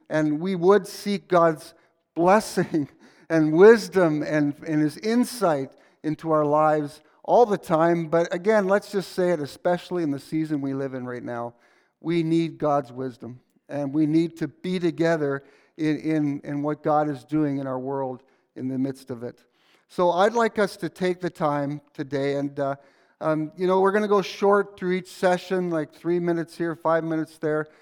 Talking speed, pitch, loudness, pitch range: 190 wpm, 160 Hz, -24 LUFS, 145-180 Hz